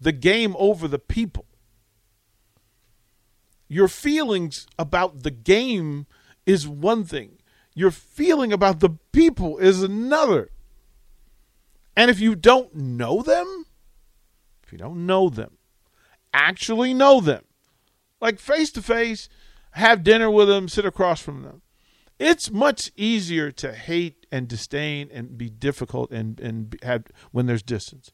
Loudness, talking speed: -21 LUFS, 130 wpm